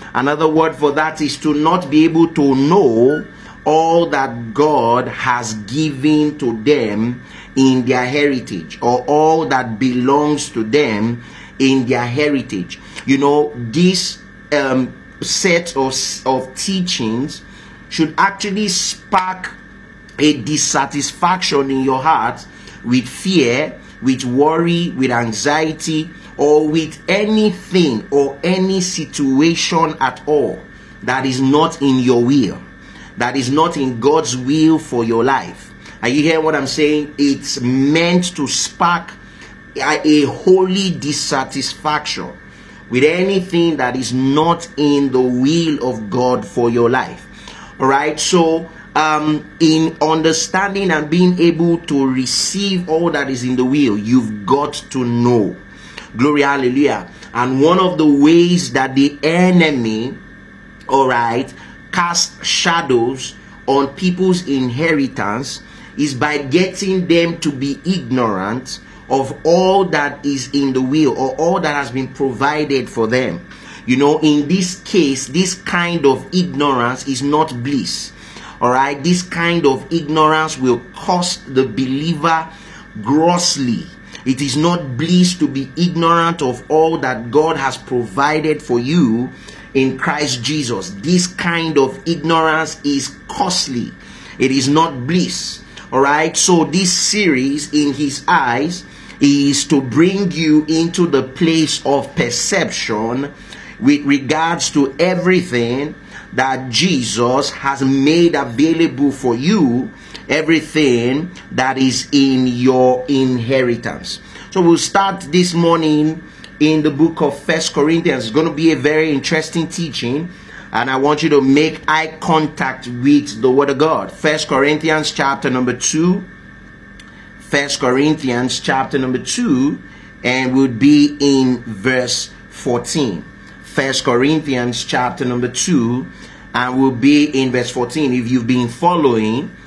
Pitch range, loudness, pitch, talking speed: 130-165 Hz, -15 LUFS, 150 Hz, 130 wpm